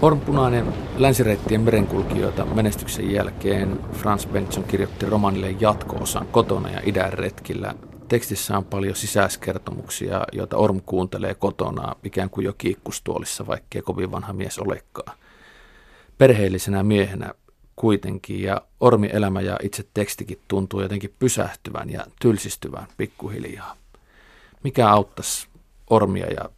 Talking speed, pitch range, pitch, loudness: 115 wpm, 95-110 Hz, 100 Hz, -23 LUFS